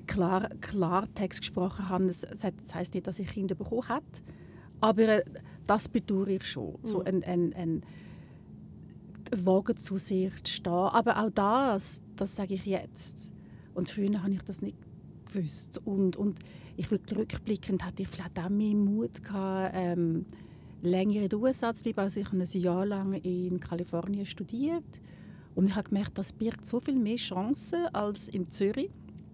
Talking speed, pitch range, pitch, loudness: 160 wpm, 185-210 Hz, 195 Hz, -31 LUFS